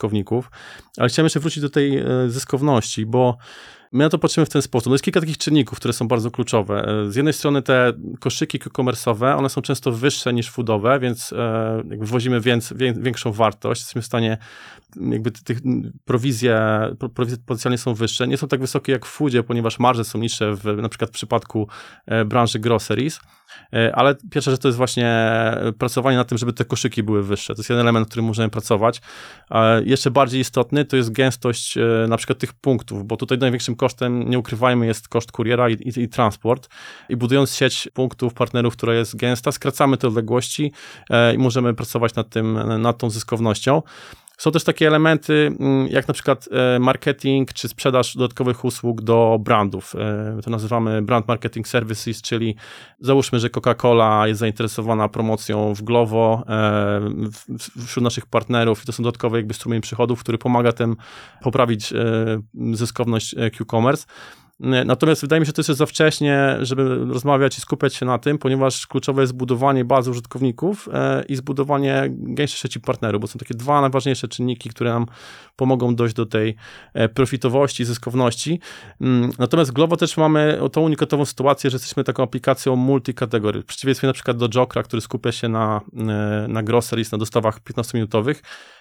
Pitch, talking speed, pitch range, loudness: 125 Hz, 165 wpm, 115-135 Hz, -20 LUFS